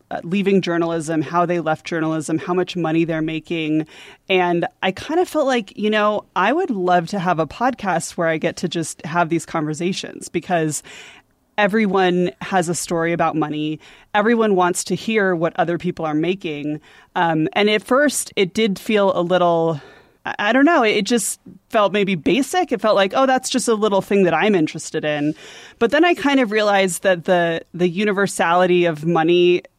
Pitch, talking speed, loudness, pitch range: 180 Hz, 185 wpm, -19 LUFS, 165-210 Hz